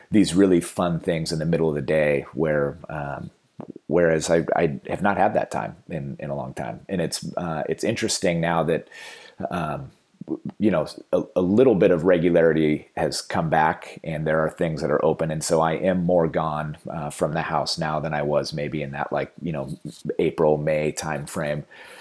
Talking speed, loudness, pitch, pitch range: 205 wpm, -23 LUFS, 80 Hz, 75-85 Hz